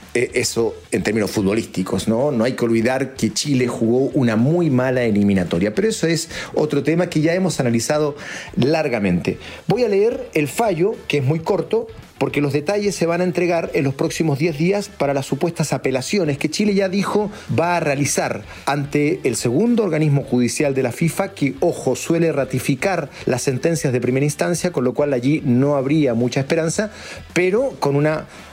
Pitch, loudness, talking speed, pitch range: 145 Hz, -19 LUFS, 180 wpm, 130-170 Hz